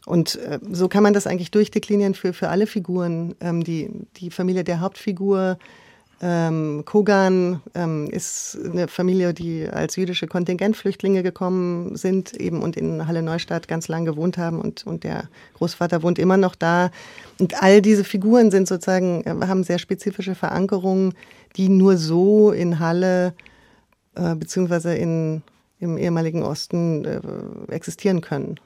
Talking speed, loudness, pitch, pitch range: 150 wpm, -21 LUFS, 180 Hz, 170-195 Hz